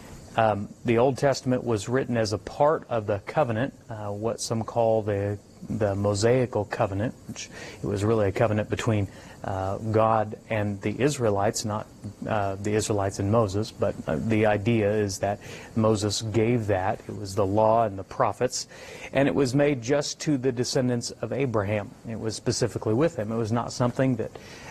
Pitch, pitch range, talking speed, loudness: 110 Hz, 105-125 Hz, 180 wpm, -26 LUFS